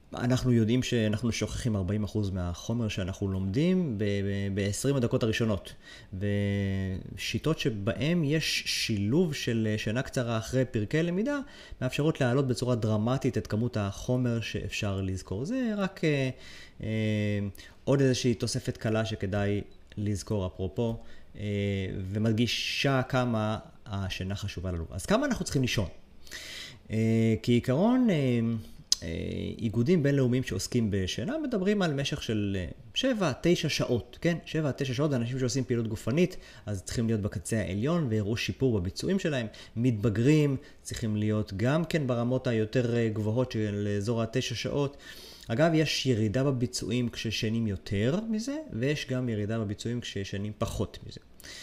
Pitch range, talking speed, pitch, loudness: 105-130 Hz, 125 wpm, 115 Hz, -29 LUFS